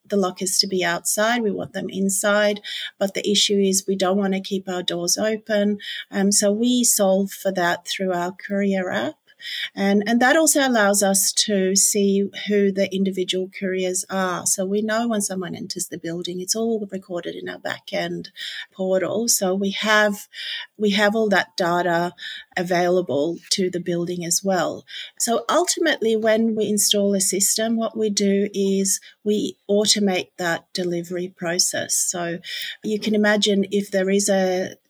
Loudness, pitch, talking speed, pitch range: -21 LUFS, 195 Hz, 165 wpm, 185-210 Hz